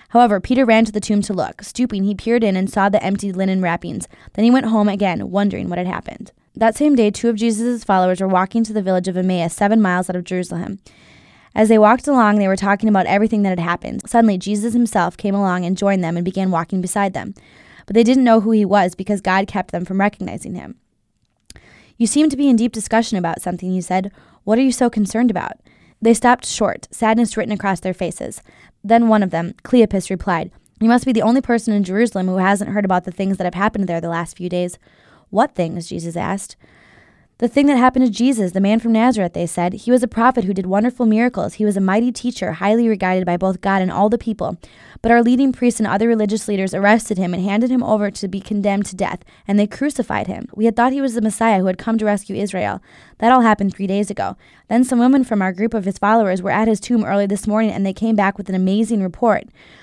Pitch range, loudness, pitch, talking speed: 190-230 Hz, -17 LUFS, 205 Hz, 245 wpm